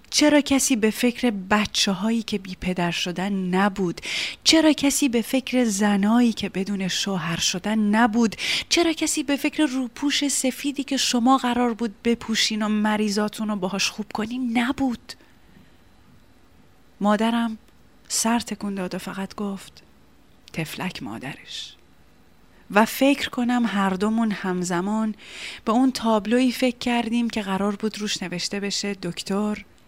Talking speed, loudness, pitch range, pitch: 135 wpm, -23 LUFS, 195-245 Hz, 215 Hz